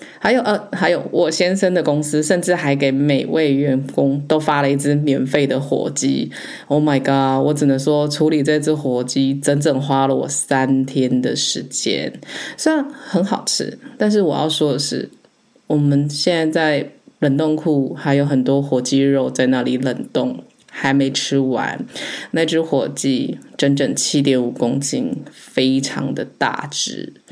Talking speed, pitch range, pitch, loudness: 240 characters per minute, 135-155 Hz, 145 Hz, -18 LUFS